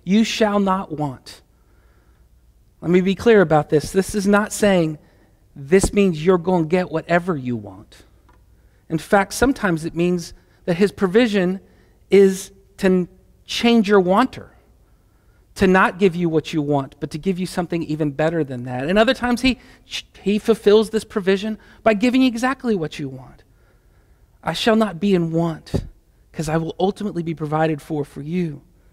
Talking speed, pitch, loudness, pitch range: 170 wpm, 180 Hz, -19 LUFS, 155-205 Hz